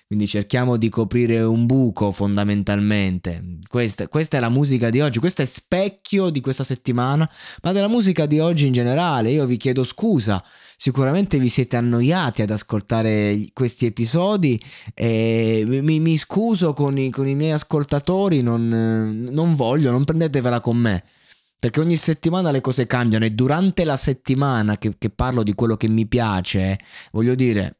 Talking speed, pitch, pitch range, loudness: 165 wpm, 125 Hz, 110-150 Hz, -20 LUFS